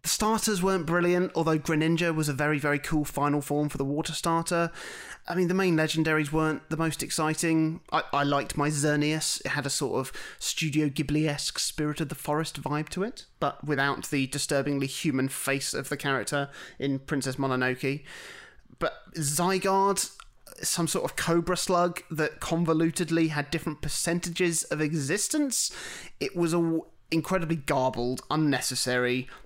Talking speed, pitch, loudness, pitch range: 160 wpm, 155 Hz, -28 LUFS, 145-170 Hz